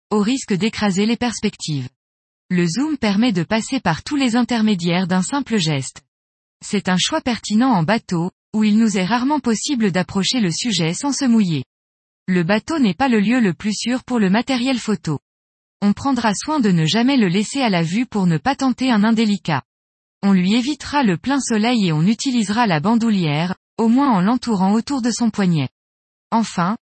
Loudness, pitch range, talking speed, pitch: -18 LUFS, 175-240 Hz, 190 wpm, 210 Hz